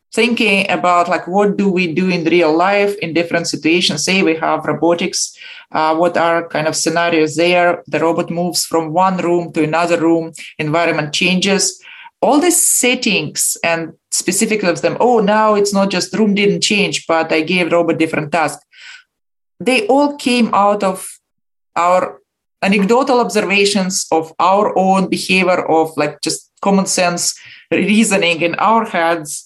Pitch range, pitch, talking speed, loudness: 165-205 Hz, 180 Hz, 155 wpm, -14 LUFS